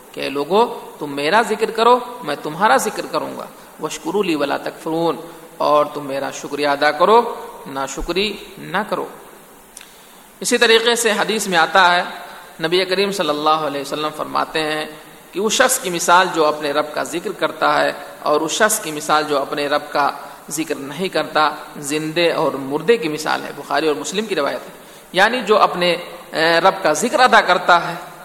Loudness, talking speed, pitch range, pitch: -17 LUFS, 180 wpm, 150-195 Hz, 160 Hz